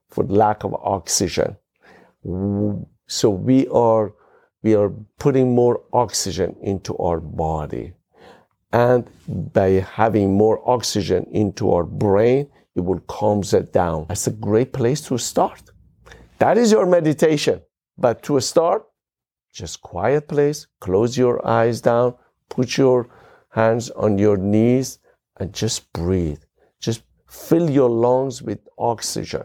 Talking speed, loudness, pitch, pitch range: 130 wpm, -19 LUFS, 110 Hz, 100-125 Hz